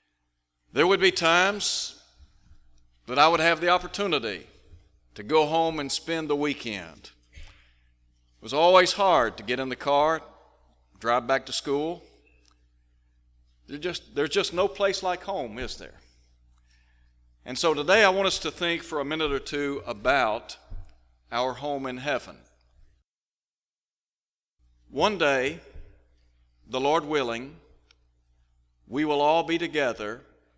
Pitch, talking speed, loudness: 115 Hz, 135 wpm, -25 LUFS